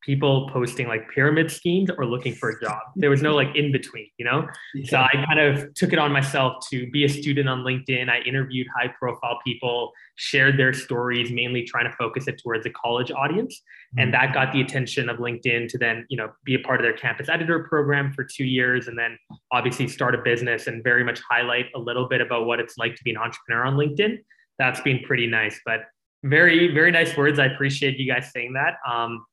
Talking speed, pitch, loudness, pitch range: 225 wpm, 130 Hz, -22 LUFS, 120-140 Hz